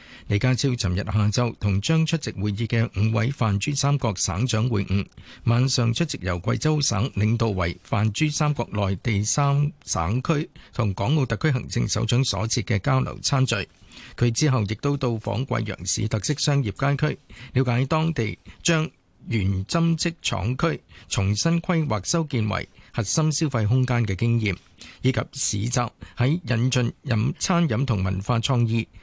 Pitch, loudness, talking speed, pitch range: 120 Hz, -24 LUFS, 240 characters per minute, 105-140 Hz